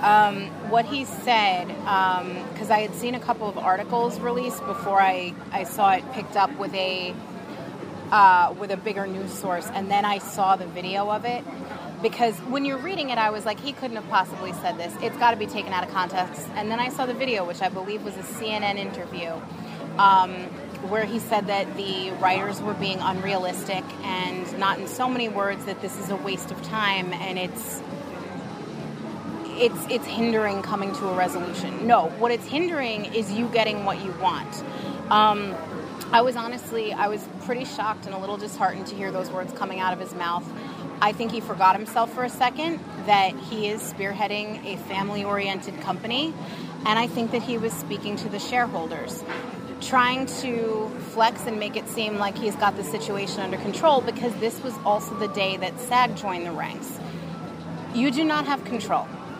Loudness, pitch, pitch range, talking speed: -25 LUFS, 210 Hz, 190-230 Hz, 195 wpm